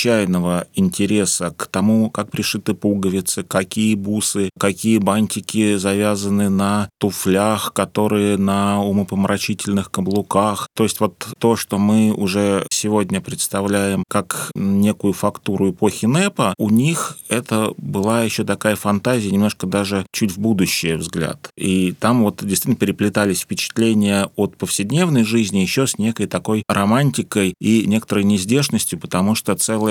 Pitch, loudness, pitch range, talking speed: 105 Hz, -18 LUFS, 100-110 Hz, 130 wpm